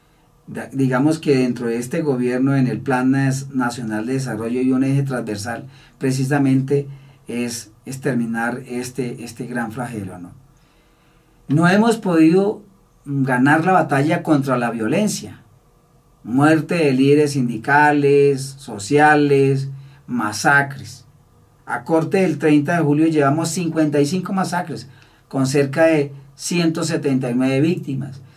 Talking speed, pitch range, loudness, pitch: 115 wpm, 125-150 Hz, -18 LUFS, 140 Hz